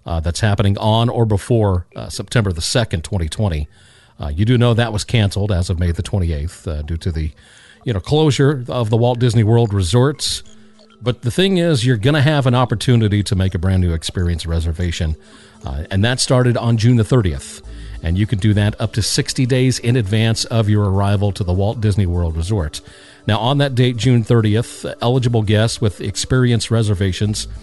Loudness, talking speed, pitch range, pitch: -17 LUFS, 200 wpm, 95-125 Hz, 110 Hz